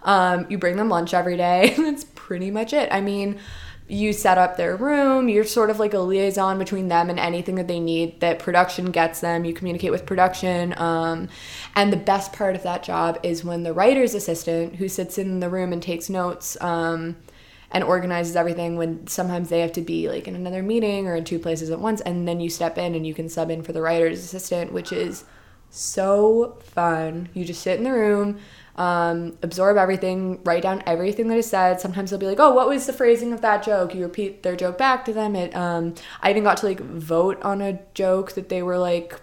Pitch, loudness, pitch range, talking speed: 180 Hz, -22 LUFS, 170-200 Hz, 225 wpm